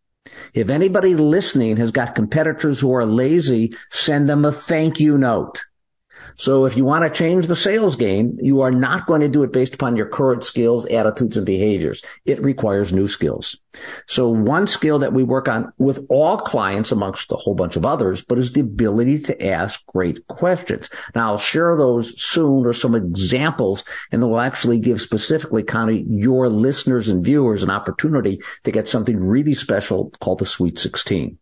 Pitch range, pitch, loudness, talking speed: 115-150 Hz, 130 Hz, -18 LUFS, 185 wpm